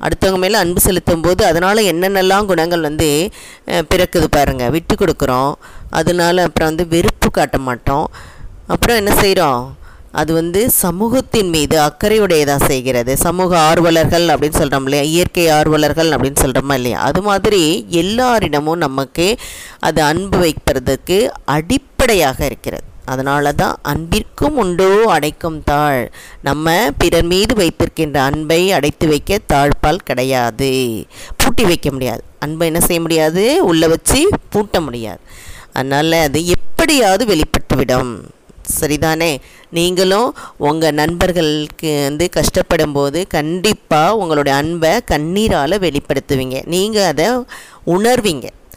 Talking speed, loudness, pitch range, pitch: 115 wpm, -14 LUFS, 145-180 Hz, 160 Hz